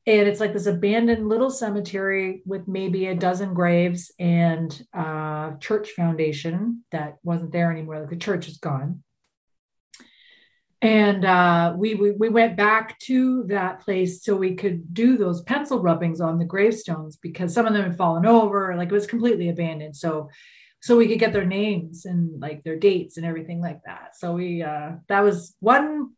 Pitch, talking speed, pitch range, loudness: 185 Hz, 180 wpm, 170-215 Hz, -22 LUFS